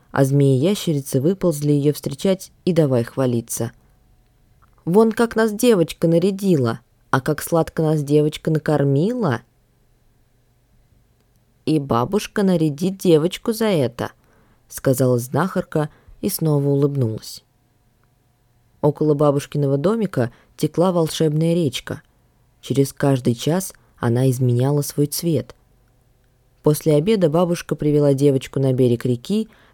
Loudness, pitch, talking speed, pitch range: -19 LUFS, 140 Hz, 105 wpm, 125-165 Hz